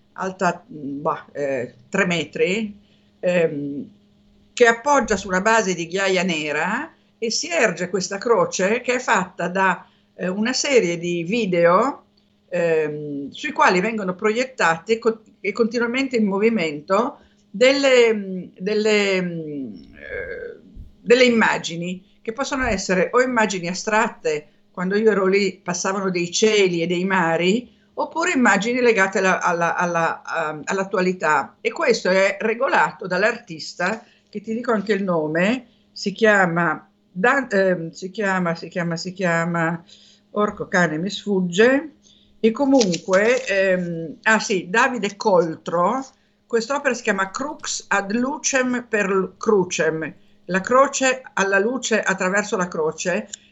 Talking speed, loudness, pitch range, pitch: 125 wpm, -20 LUFS, 180-230 Hz, 200 Hz